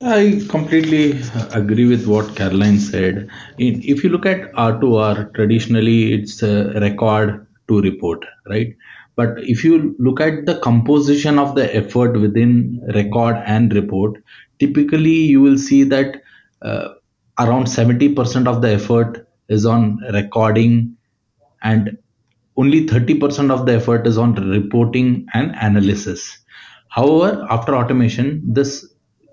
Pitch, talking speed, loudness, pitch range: 115 Hz, 135 wpm, -16 LUFS, 110-135 Hz